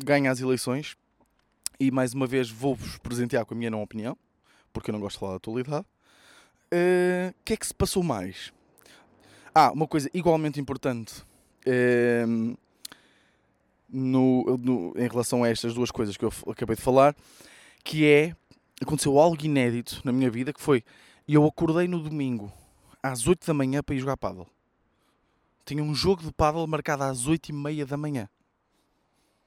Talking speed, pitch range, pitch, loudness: 170 wpm, 120-150 Hz, 135 Hz, -26 LUFS